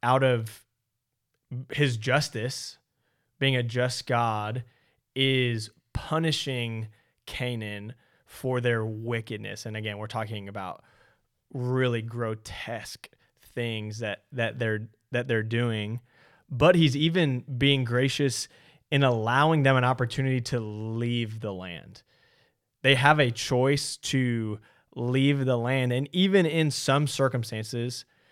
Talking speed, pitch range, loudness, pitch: 115 wpm, 115-135 Hz, -27 LUFS, 125 Hz